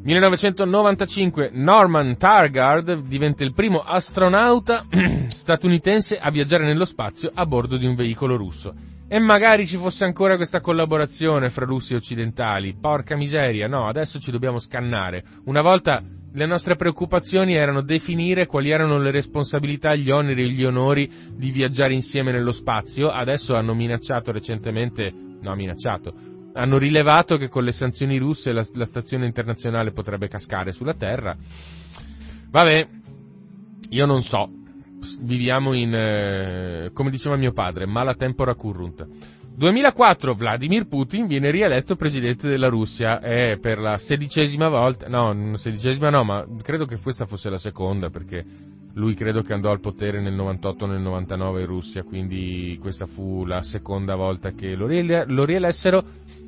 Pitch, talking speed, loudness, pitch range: 130 Hz, 150 wpm, -21 LUFS, 105-155 Hz